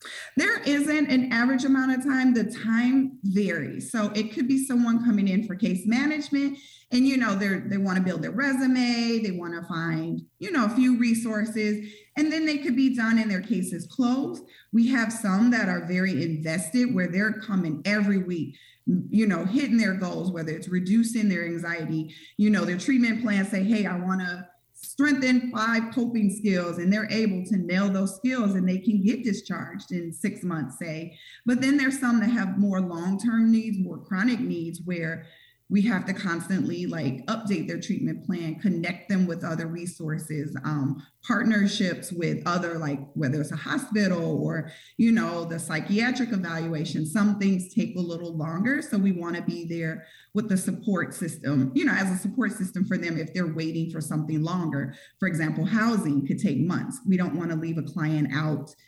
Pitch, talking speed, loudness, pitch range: 195 Hz, 195 wpm, -26 LUFS, 170-230 Hz